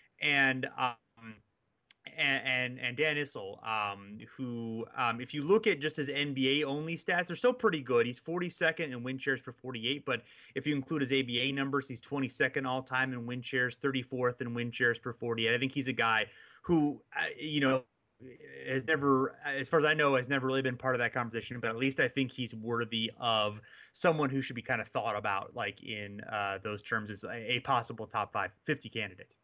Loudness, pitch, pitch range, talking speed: -32 LUFS, 130 Hz, 120-140 Hz, 210 wpm